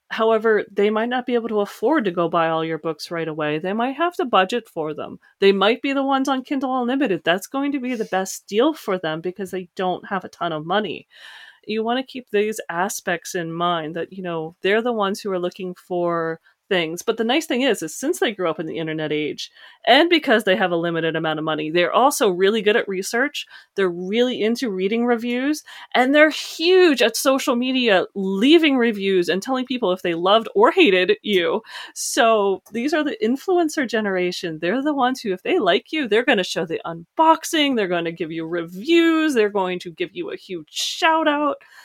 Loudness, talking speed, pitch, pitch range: -20 LUFS, 215 wpm, 205 Hz, 180-260 Hz